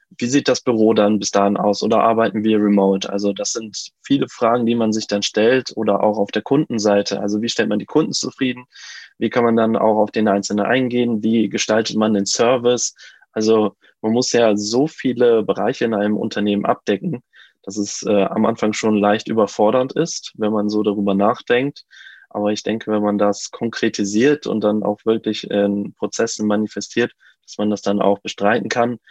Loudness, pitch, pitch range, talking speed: -18 LUFS, 110 Hz, 105-115 Hz, 195 wpm